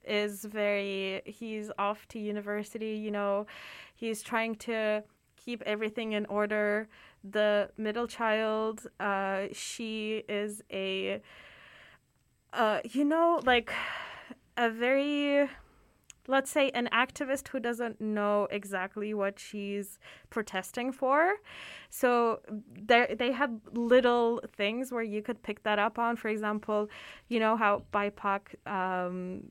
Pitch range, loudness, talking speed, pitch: 205-240 Hz, -31 LUFS, 120 wpm, 215 Hz